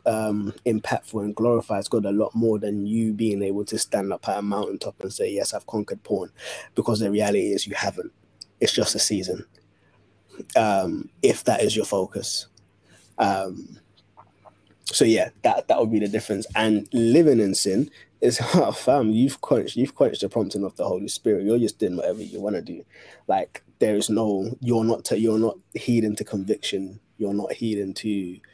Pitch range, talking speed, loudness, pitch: 100-115 Hz, 190 wpm, -23 LUFS, 105 Hz